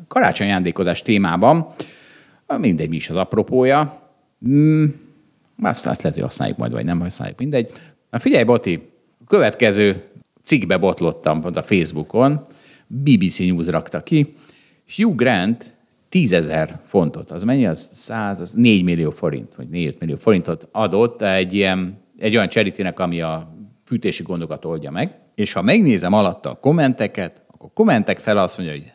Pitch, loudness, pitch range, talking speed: 100 Hz, -18 LUFS, 85-140 Hz, 155 wpm